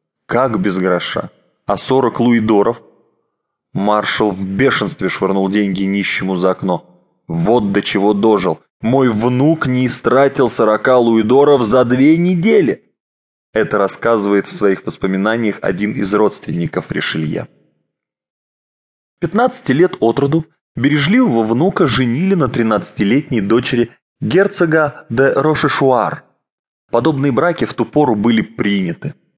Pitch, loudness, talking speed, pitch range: 115 Hz, -15 LUFS, 115 wpm, 100-140 Hz